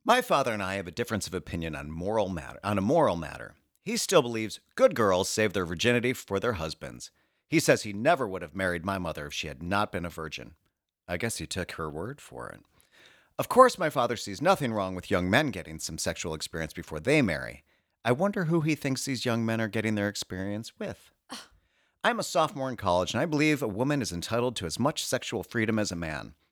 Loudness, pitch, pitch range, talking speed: -28 LUFS, 105 Hz, 90-130 Hz, 230 wpm